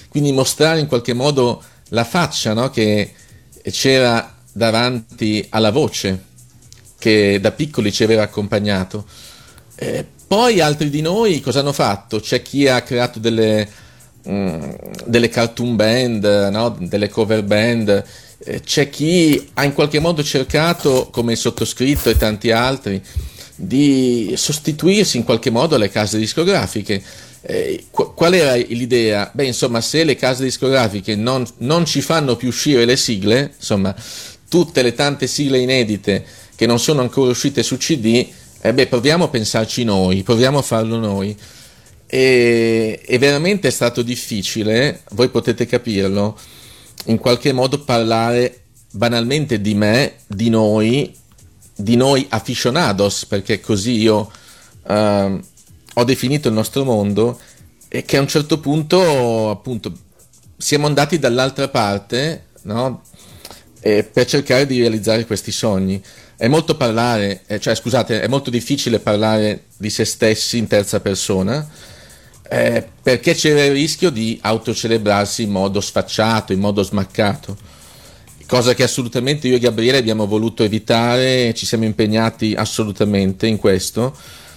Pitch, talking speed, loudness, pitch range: 115 Hz, 140 wpm, -16 LUFS, 105-130 Hz